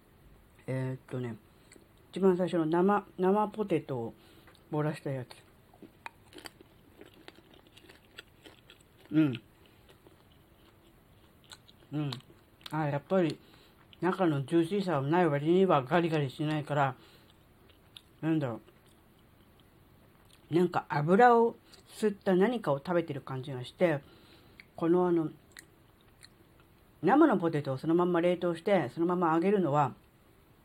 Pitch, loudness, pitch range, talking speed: 150 Hz, -30 LUFS, 115-175 Hz, 210 characters per minute